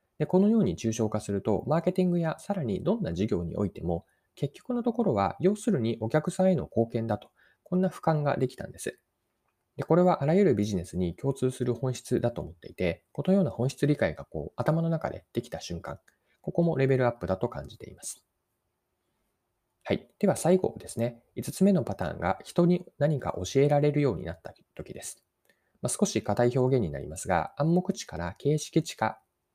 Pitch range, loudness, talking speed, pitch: 115-175 Hz, -28 LUFS, 380 characters per minute, 140 Hz